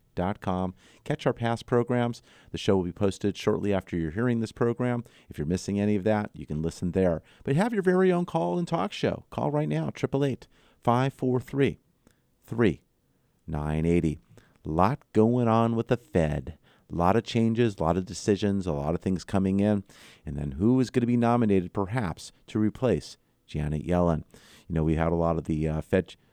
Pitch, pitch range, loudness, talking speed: 100 Hz, 85-120 Hz, -27 LUFS, 190 wpm